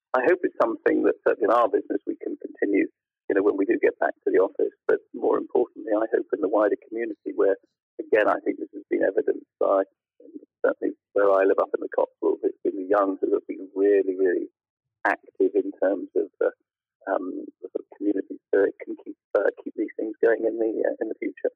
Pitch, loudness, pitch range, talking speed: 390 Hz, -25 LUFS, 335-435 Hz, 230 wpm